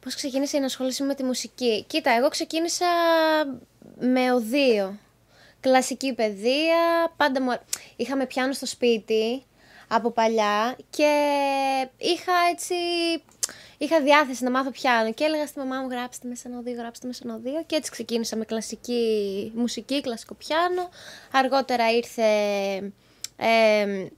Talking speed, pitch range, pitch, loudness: 130 wpm, 230-295 Hz, 255 Hz, -24 LUFS